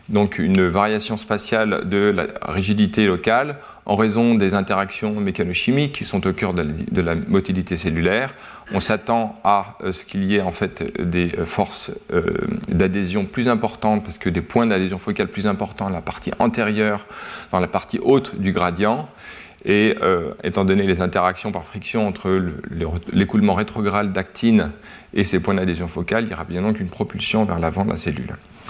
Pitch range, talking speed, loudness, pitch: 95-110 Hz, 175 wpm, -20 LUFS, 100 Hz